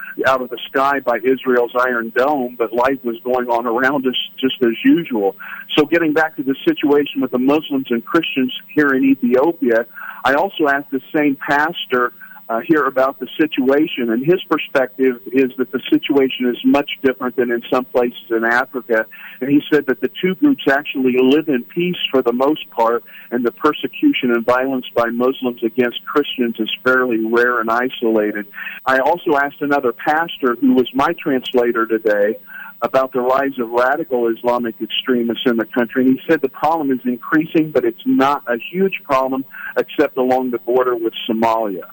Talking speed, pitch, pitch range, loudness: 180 wpm, 130 Hz, 120-145 Hz, -17 LUFS